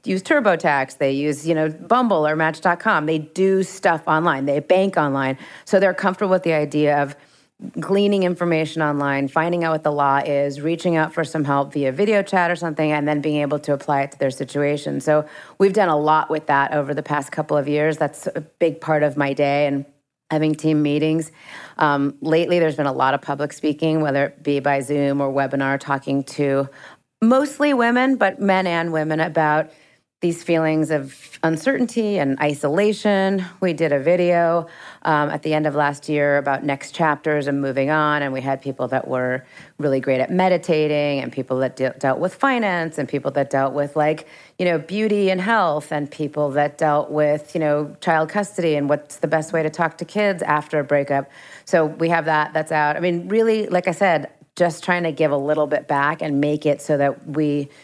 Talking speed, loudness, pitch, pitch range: 205 wpm, -20 LUFS, 150 Hz, 145-170 Hz